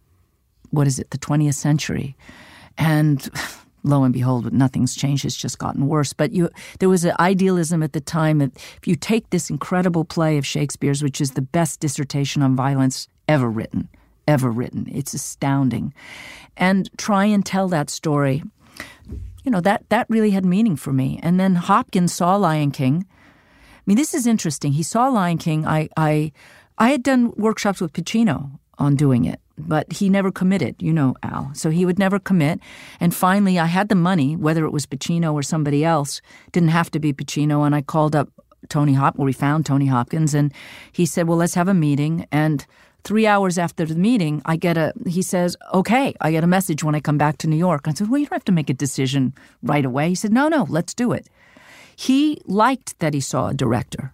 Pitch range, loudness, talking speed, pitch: 145-185 Hz, -20 LUFS, 205 wpm, 160 Hz